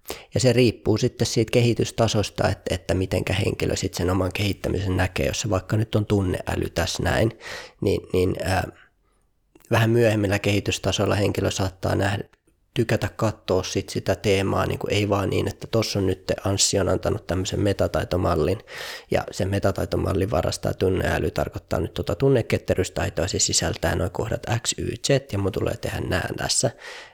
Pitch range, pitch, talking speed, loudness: 95-110 Hz, 100 Hz, 155 wpm, -23 LUFS